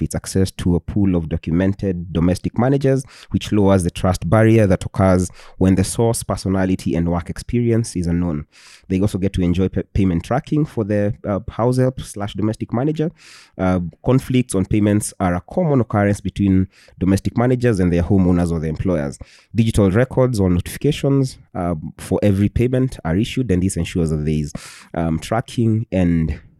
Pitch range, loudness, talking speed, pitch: 90-115 Hz, -19 LUFS, 175 wpm, 95 Hz